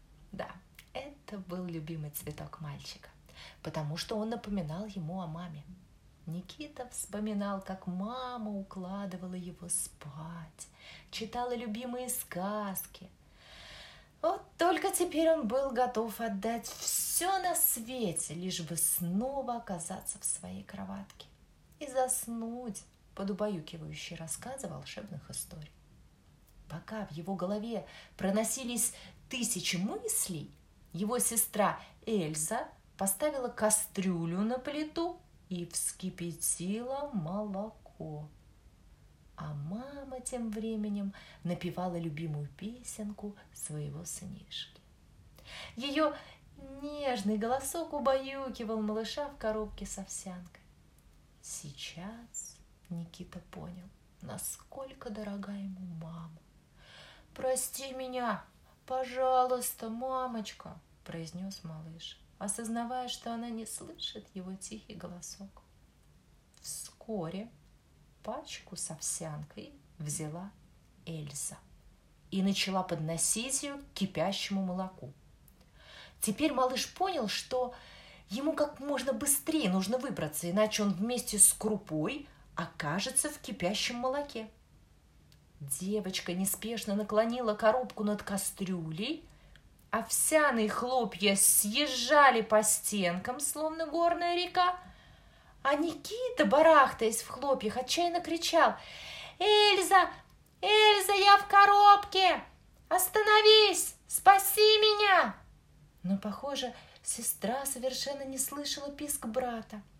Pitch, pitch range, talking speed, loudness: 215 Hz, 180-265 Hz, 95 wpm, -31 LUFS